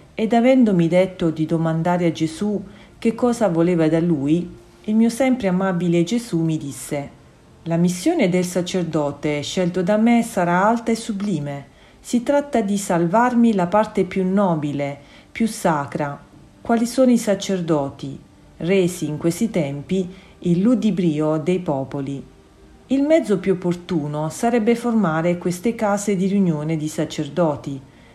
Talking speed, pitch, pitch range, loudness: 135 wpm, 180 Hz, 160-215 Hz, -20 LUFS